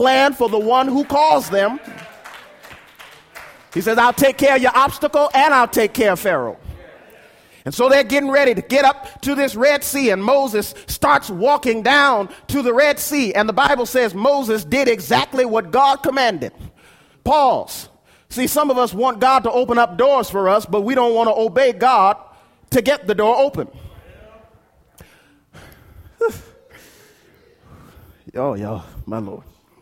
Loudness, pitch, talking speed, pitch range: -16 LUFS, 255 Hz, 165 wpm, 230-275 Hz